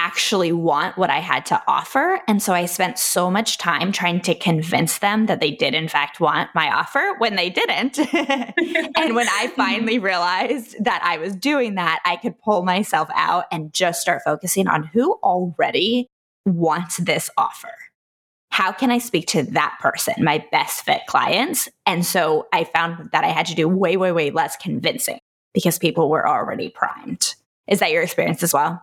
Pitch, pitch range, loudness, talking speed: 185 Hz, 170-240 Hz, -20 LUFS, 185 wpm